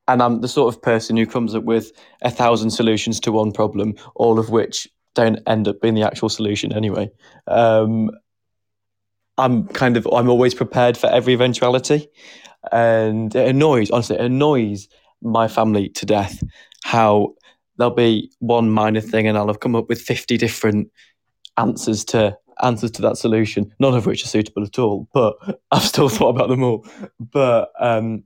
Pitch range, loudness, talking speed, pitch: 110-120 Hz, -18 LUFS, 175 wpm, 115 Hz